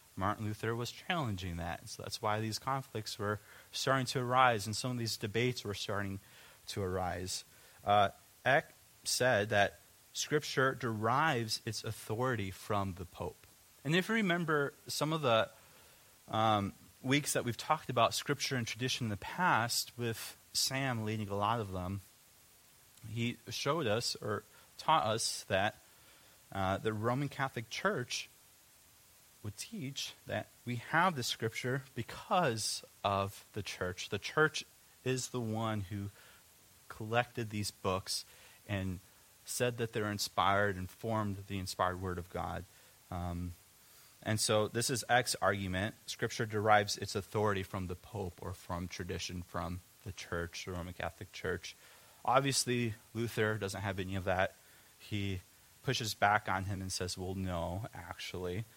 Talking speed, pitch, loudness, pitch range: 150 wpm, 110 Hz, -35 LUFS, 95-120 Hz